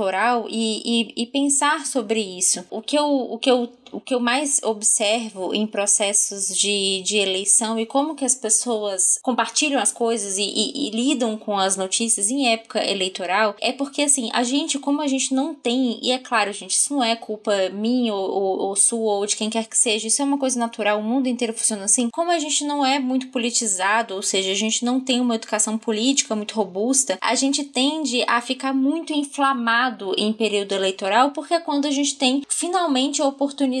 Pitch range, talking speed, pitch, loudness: 215-270 Hz, 210 wpm, 235 Hz, -20 LUFS